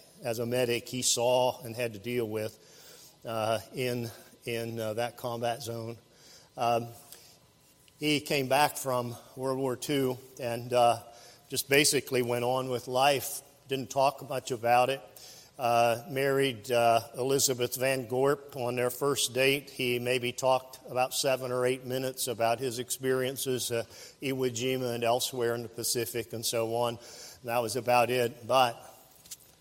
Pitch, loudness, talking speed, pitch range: 125 Hz, -29 LUFS, 155 wpm, 120-130 Hz